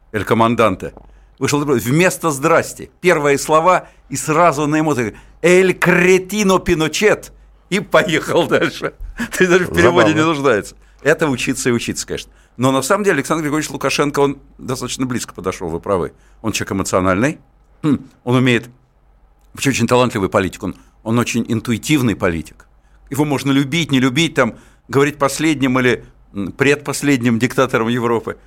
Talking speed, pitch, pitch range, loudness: 140 wpm, 140 Hz, 120-155 Hz, -16 LUFS